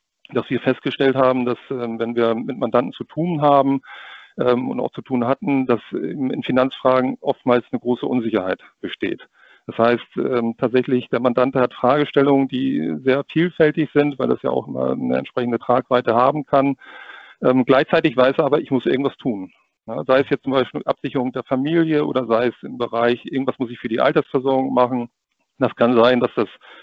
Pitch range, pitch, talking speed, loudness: 120-135 Hz, 130 Hz, 175 wpm, -19 LUFS